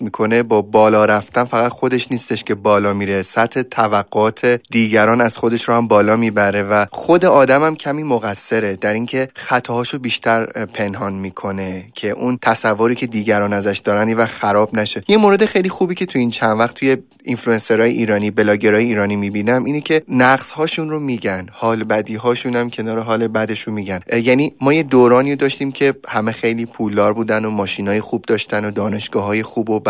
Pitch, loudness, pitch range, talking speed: 115 Hz, -16 LUFS, 105-125 Hz, 180 wpm